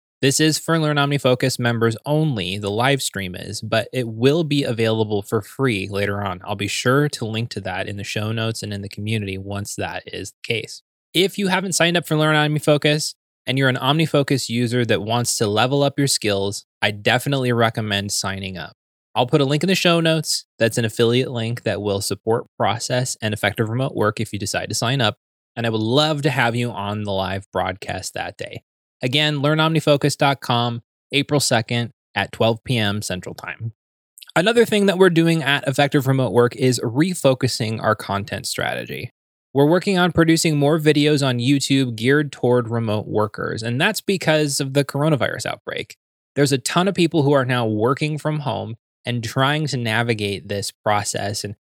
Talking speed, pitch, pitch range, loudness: 190 wpm, 125 Hz, 110-145 Hz, -20 LUFS